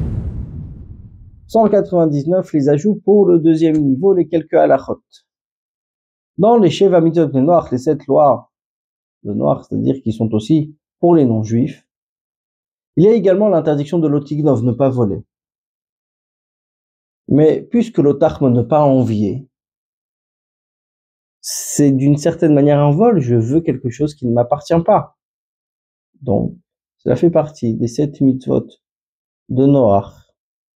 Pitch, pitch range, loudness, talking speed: 145 Hz, 125-165 Hz, -15 LUFS, 130 wpm